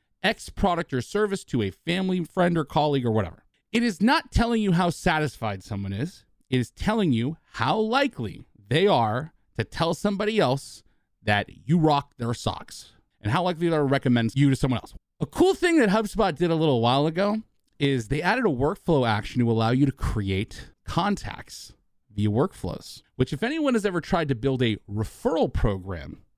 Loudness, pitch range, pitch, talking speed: -25 LUFS, 120-190 Hz, 145 Hz, 190 wpm